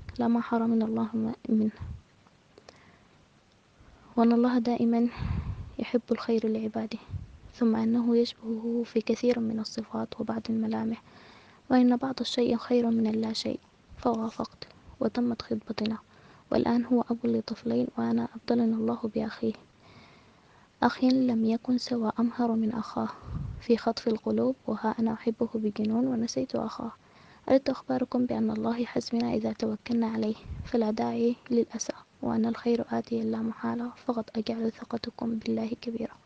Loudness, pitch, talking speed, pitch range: -29 LUFS, 230 Hz, 125 wpm, 225-240 Hz